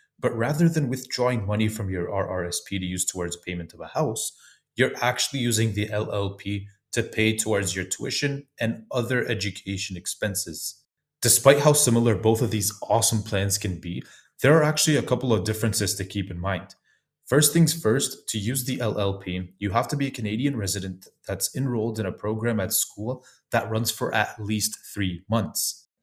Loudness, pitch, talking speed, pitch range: -25 LUFS, 110 Hz, 180 wpm, 100-125 Hz